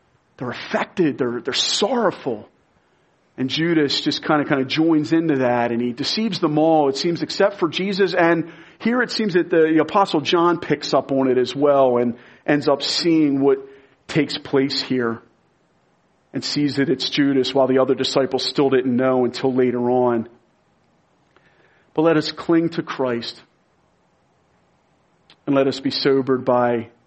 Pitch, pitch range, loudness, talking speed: 140 Hz, 130-165 Hz, -19 LUFS, 165 wpm